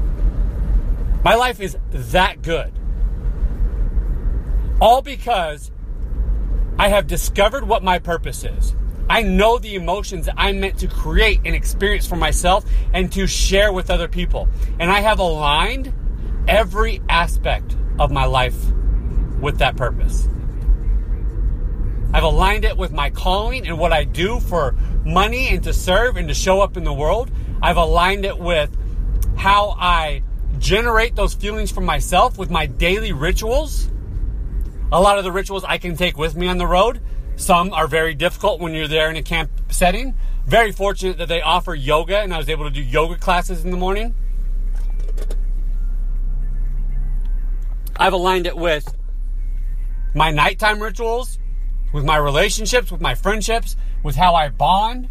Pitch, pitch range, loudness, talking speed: 175 Hz, 145-195 Hz, -19 LUFS, 150 wpm